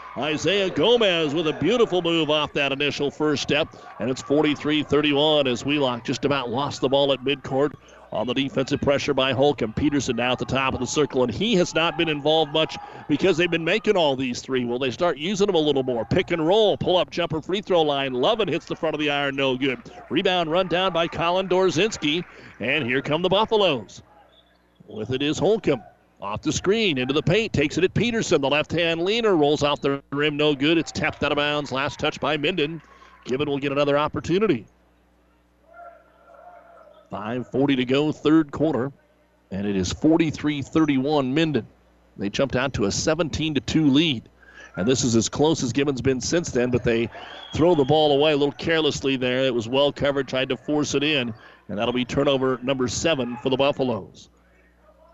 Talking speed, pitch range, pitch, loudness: 195 wpm, 130-160 Hz, 145 Hz, -22 LUFS